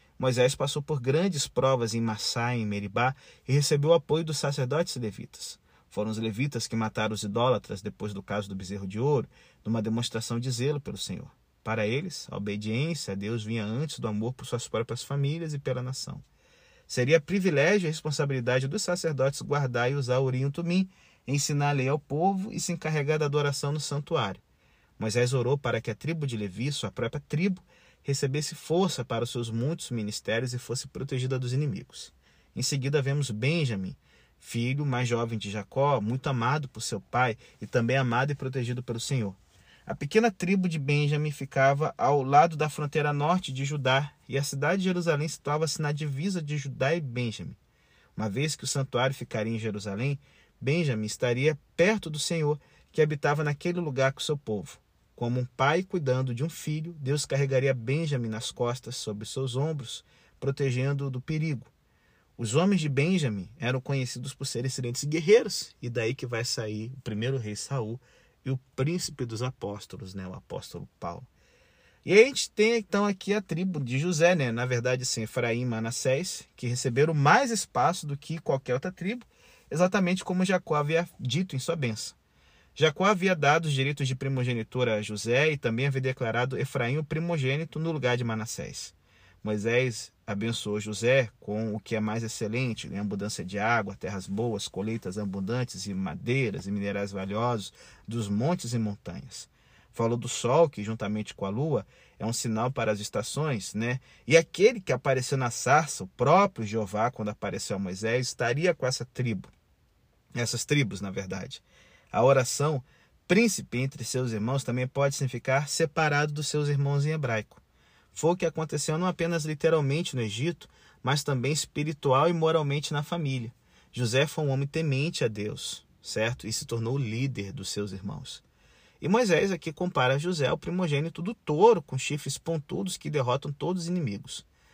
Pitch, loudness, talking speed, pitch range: 135 Hz, -28 LUFS, 175 wpm, 115-155 Hz